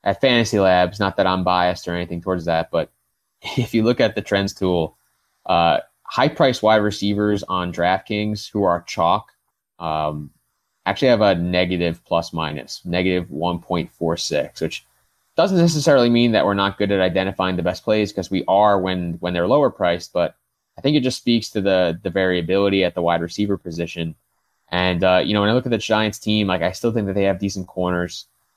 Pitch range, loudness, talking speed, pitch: 90-105 Hz, -20 LUFS, 195 wpm, 95 Hz